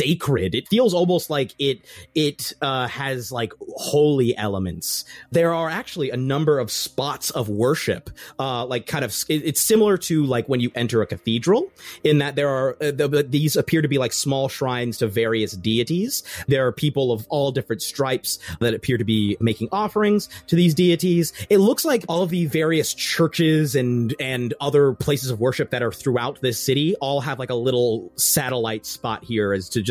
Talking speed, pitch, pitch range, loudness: 195 wpm, 135 Hz, 120-155 Hz, -21 LUFS